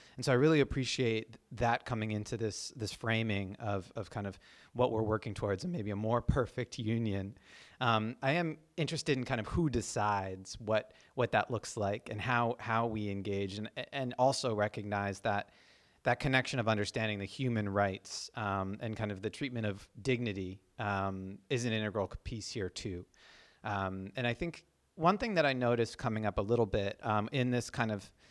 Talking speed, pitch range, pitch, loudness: 190 wpm, 100-125 Hz, 110 Hz, -35 LUFS